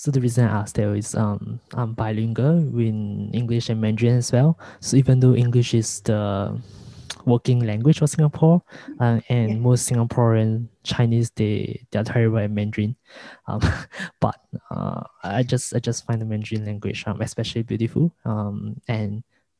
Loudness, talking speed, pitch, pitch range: -22 LUFS, 155 wpm, 115 Hz, 105-125 Hz